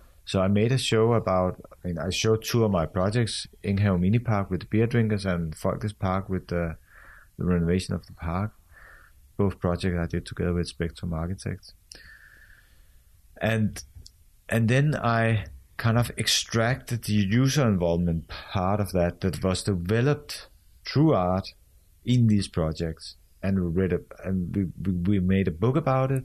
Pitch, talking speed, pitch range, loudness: 95 Hz, 160 wpm, 85-110 Hz, -26 LUFS